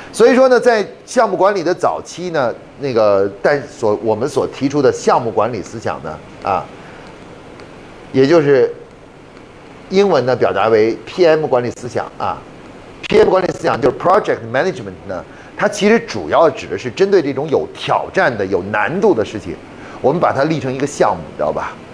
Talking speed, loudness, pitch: 300 characters per minute, -15 LUFS, 185 Hz